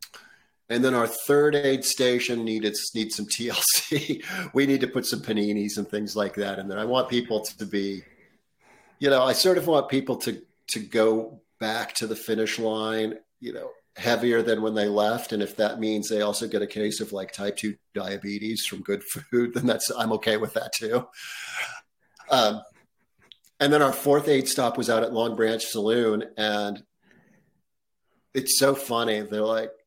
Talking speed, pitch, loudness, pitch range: 185 wpm, 110 Hz, -25 LUFS, 105-125 Hz